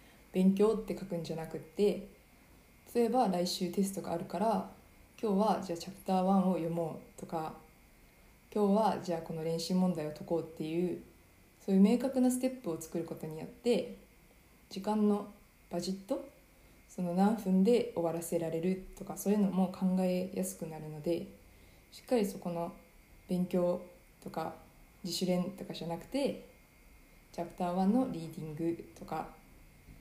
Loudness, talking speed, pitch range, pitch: -34 LUFS, 310 characters per minute, 165-205 Hz, 180 Hz